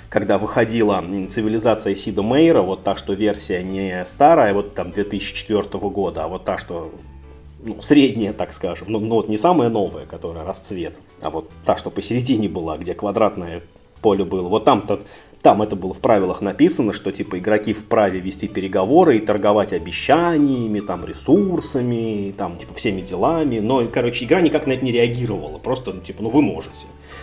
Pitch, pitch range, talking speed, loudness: 105 Hz, 95-115 Hz, 165 wpm, -19 LUFS